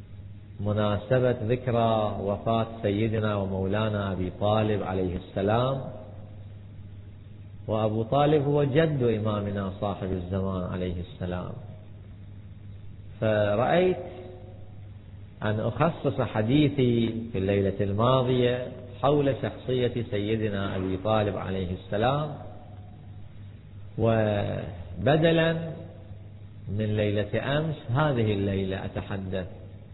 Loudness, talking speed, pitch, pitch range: -27 LUFS, 80 wpm, 105 Hz, 100-115 Hz